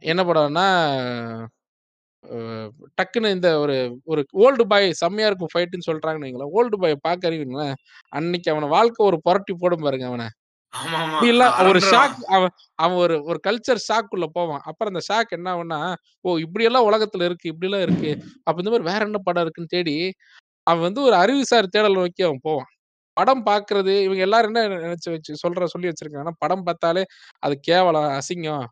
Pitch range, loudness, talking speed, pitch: 155-200 Hz, -20 LUFS, 165 wpm, 175 Hz